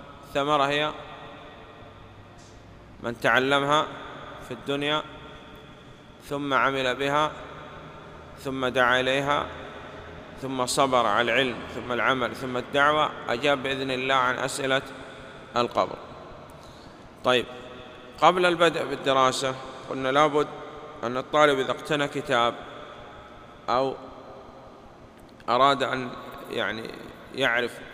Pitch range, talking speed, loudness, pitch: 125-150 Hz, 90 wpm, -25 LUFS, 135 Hz